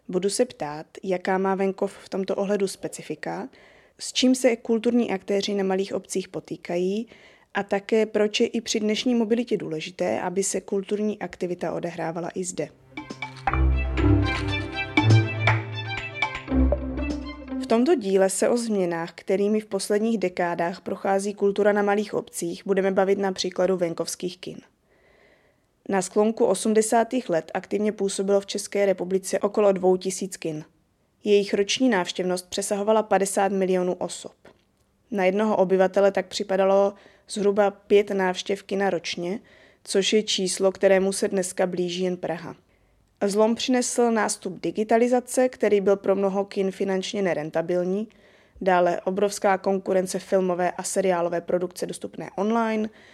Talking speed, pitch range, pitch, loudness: 130 wpm, 180-210 Hz, 195 Hz, -24 LUFS